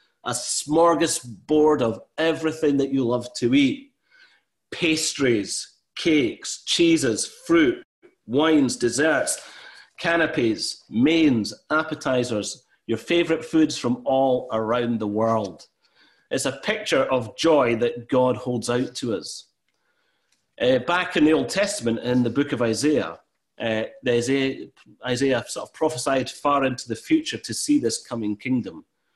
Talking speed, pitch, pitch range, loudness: 130 wpm, 145 Hz, 120-180 Hz, -22 LUFS